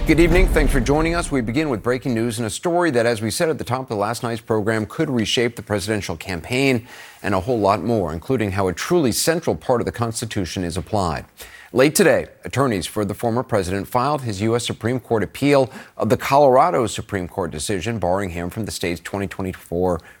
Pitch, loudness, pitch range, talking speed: 115 Hz, -20 LUFS, 100-125 Hz, 215 wpm